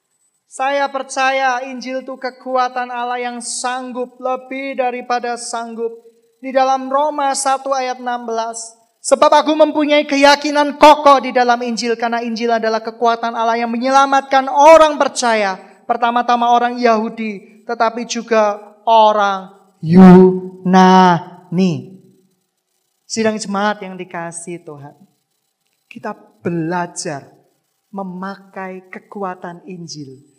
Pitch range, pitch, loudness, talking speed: 195-255 Hz, 230 Hz, -14 LUFS, 100 wpm